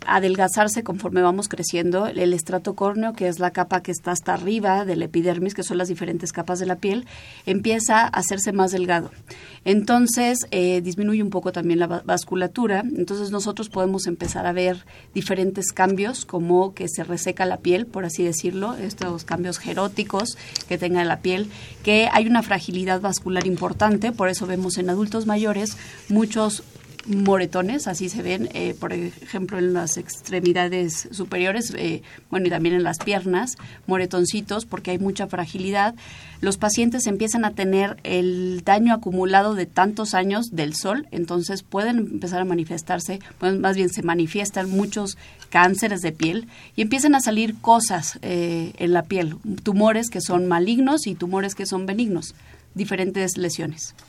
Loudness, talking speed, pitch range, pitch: -22 LUFS, 160 wpm, 180-205 Hz, 185 Hz